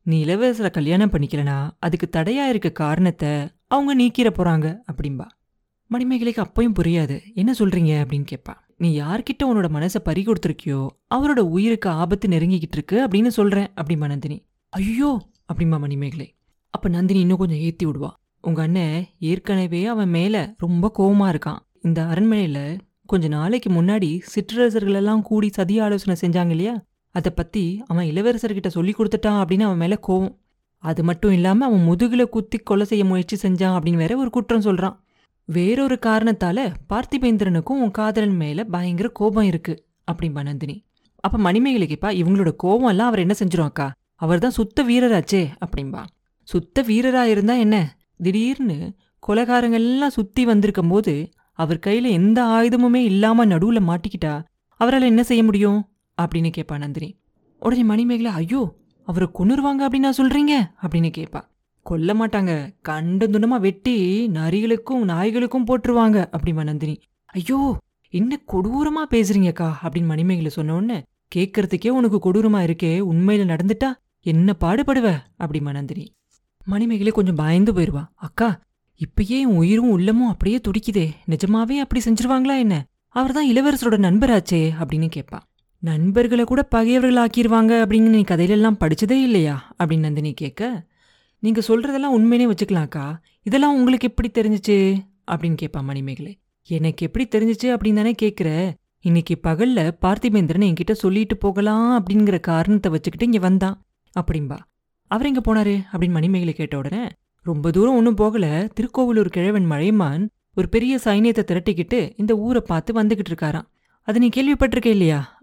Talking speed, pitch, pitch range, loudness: 135 wpm, 200 Hz, 170-230 Hz, -20 LUFS